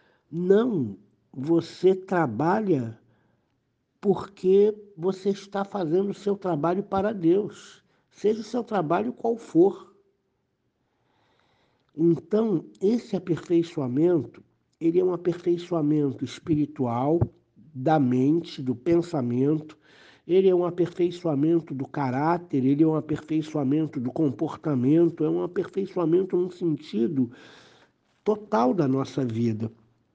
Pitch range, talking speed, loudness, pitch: 140-190 Hz, 100 wpm, -25 LUFS, 165 Hz